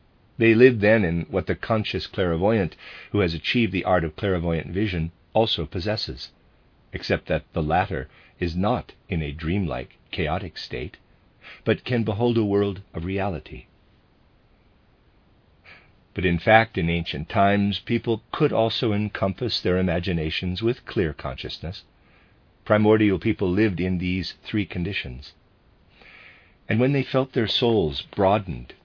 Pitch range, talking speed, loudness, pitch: 85-110 Hz, 135 wpm, -23 LUFS, 95 Hz